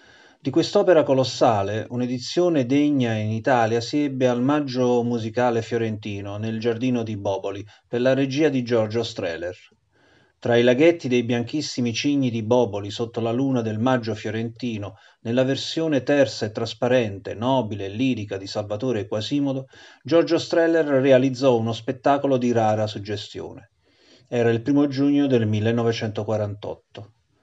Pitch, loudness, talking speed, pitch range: 120 Hz, -22 LUFS, 135 wpm, 110-135 Hz